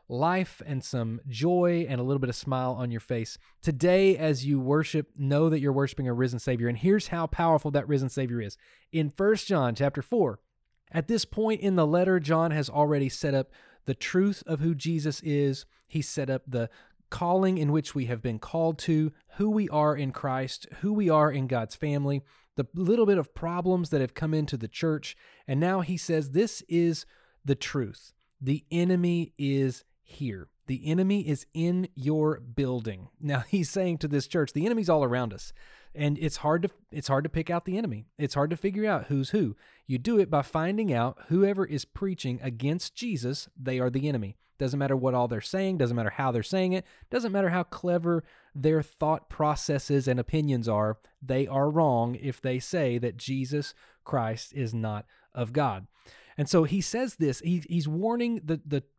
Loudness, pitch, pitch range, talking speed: -28 LUFS, 150 Hz, 130-170 Hz, 200 wpm